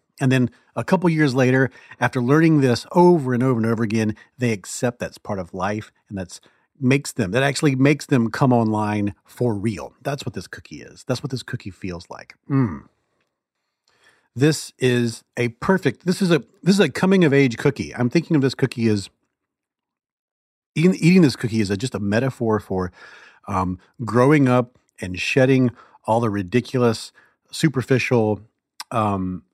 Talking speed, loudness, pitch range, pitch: 175 wpm, -20 LUFS, 110-140 Hz, 125 Hz